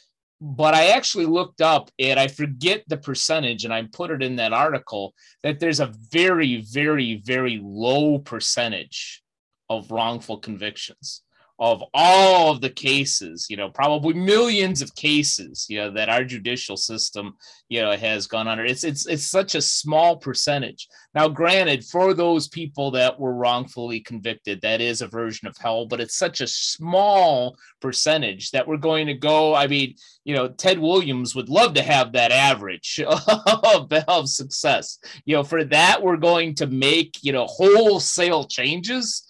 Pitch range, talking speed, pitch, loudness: 120-165 Hz, 170 wpm, 145 Hz, -20 LUFS